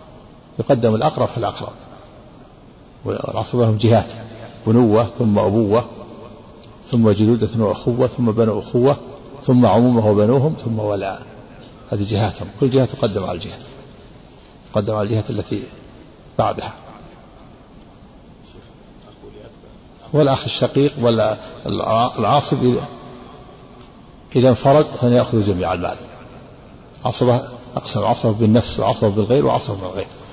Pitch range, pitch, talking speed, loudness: 110-125 Hz, 115 Hz, 105 wpm, -18 LUFS